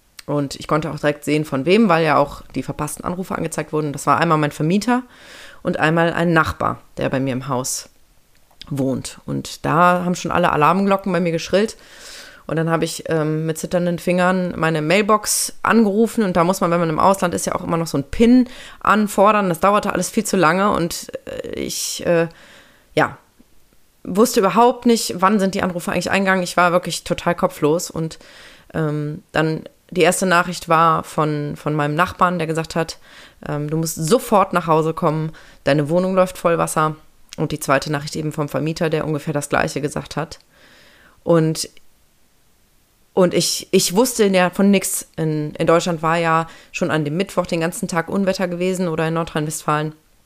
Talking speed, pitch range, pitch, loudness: 185 wpm, 155-190 Hz, 170 Hz, -19 LUFS